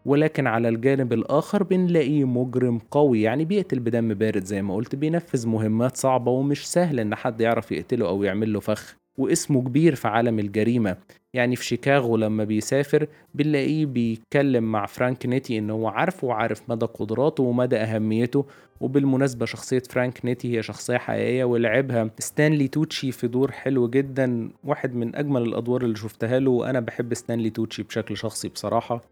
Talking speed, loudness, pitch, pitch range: 160 wpm, -24 LUFS, 125 Hz, 115-135 Hz